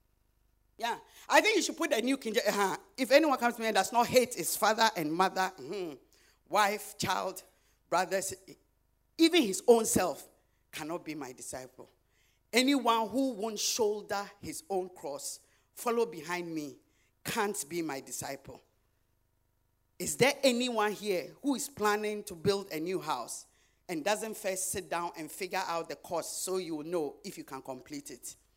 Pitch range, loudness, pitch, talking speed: 160-230 Hz, -31 LUFS, 195 Hz, 165 wpm